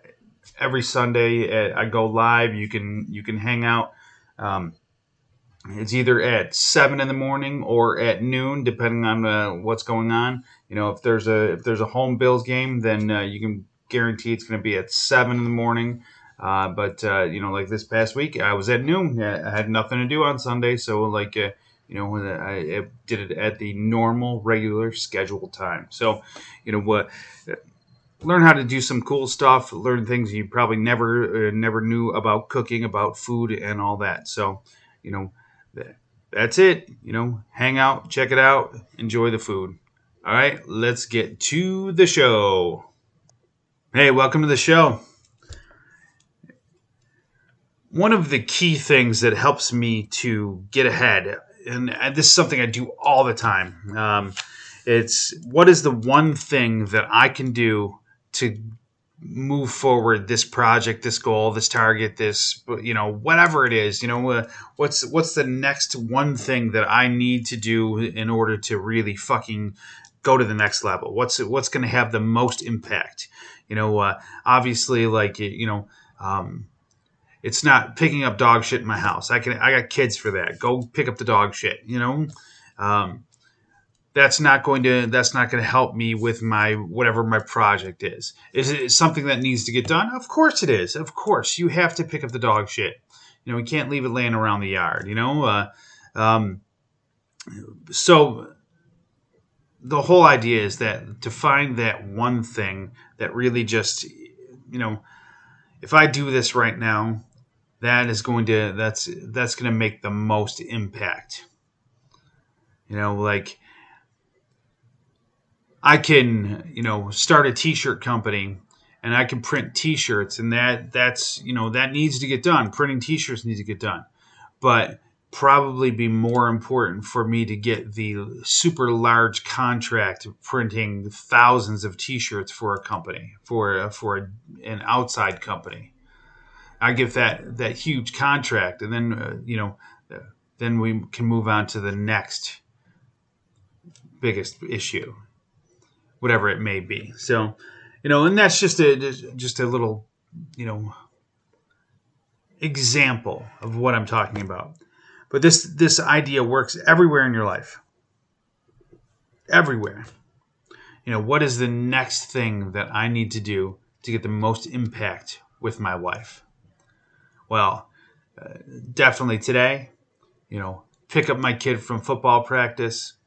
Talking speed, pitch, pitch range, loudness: 170 wpm, 120 Hz, 110-130 Hz, -20 LUFS